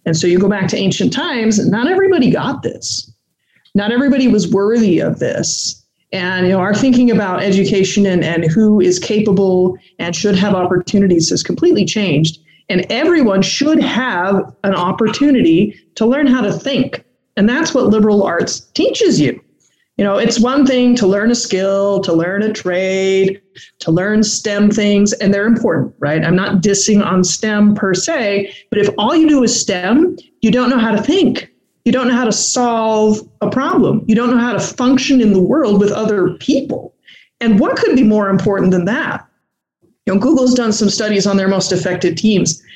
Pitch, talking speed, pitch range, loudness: 210 Hz, 190 wpm, 190-240 Hz, -13 LUFS